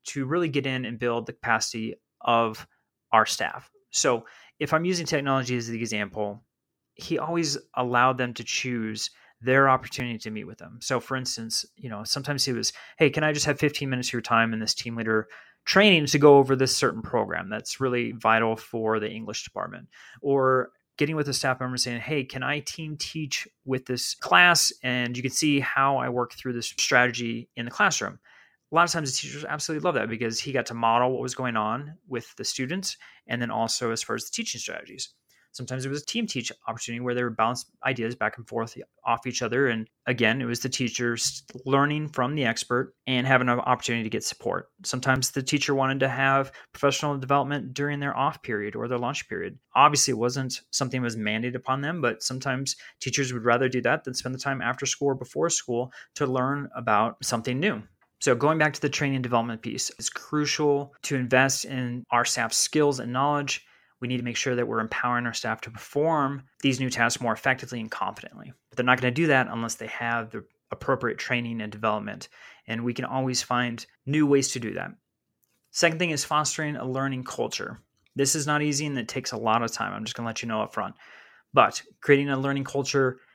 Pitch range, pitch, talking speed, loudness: 120-140 Hz, 130 Hz, 215 wpm, -26 LUFS